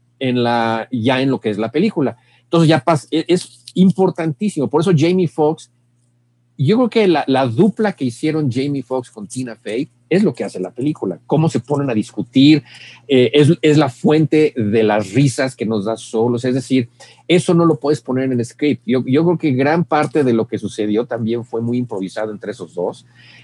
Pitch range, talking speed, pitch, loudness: 120-155 Hz, 205 wpm, 130 Hz, -17 LUFS